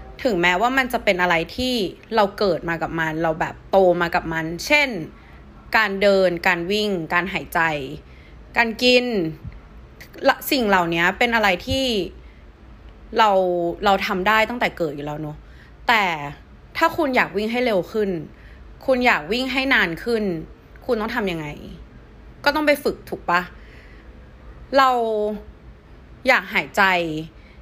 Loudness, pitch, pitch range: -20 LUFS, 190 Hz, 165-230 Hz